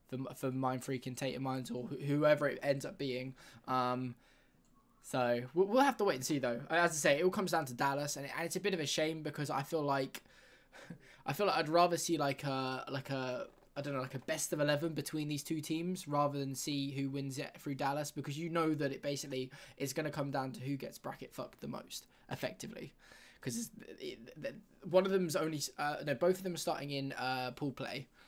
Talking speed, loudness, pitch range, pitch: 225 wpm, -36 LUFS, 135-170 Hz, 145 Hz